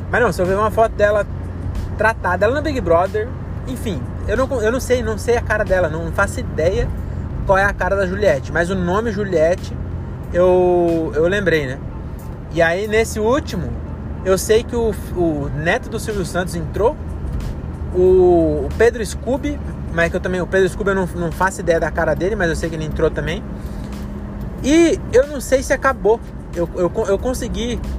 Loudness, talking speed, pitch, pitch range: -18 LUFS, 195 wpm, 185 Hz, 170-220 Hz